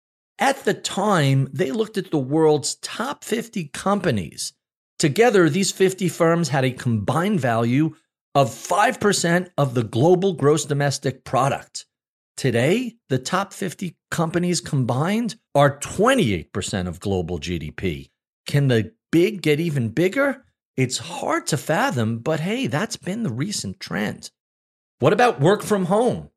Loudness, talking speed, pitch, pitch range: -21 LUFS, 135 wpm, 155 Hz, 130-190 Hz